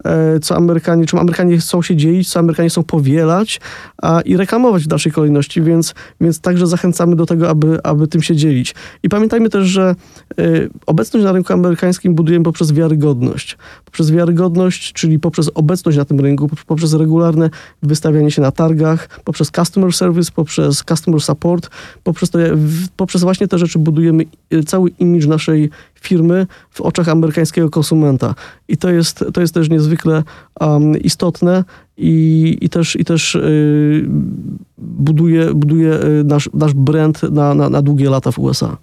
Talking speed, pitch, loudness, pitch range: 160 wpm, 165 Hz, -13 LUFS, 155-175 Hz